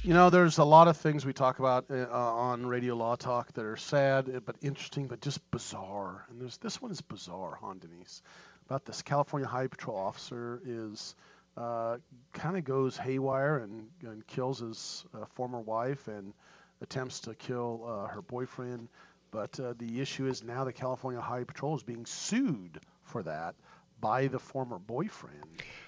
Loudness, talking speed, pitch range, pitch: -32 LUFS, 180 wpm, 115-135 Hz, 125 Hz